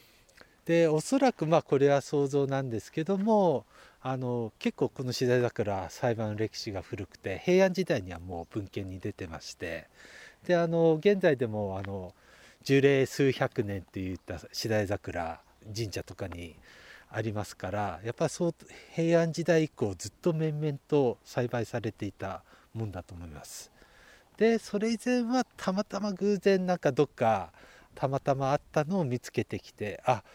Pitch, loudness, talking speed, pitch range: 130 Hz, -30 LUFS, 300 characters per minute, 105-170 Hz